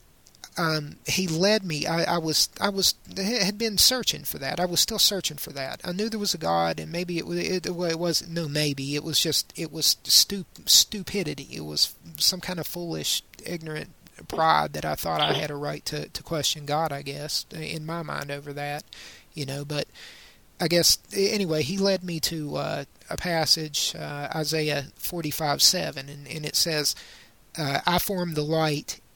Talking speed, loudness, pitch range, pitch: 195 wpm, -25 LUFS, 145-180 Hz, 160 Hz